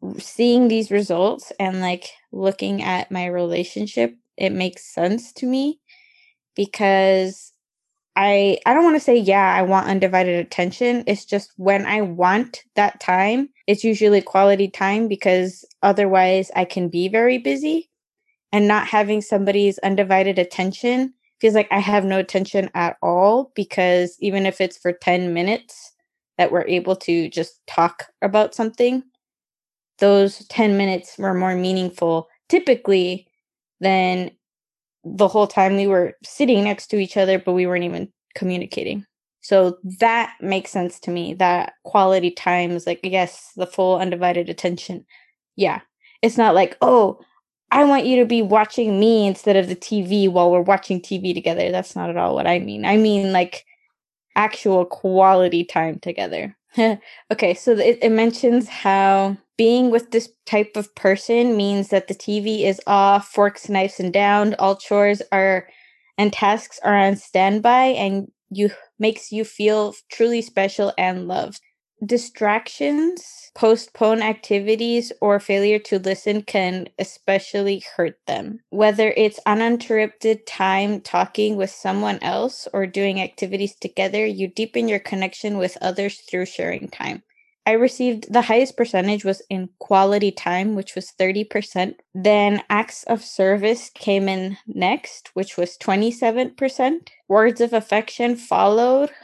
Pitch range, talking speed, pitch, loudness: 185-220 Hz, 150 wpm, 200 Hz, -19 LUFS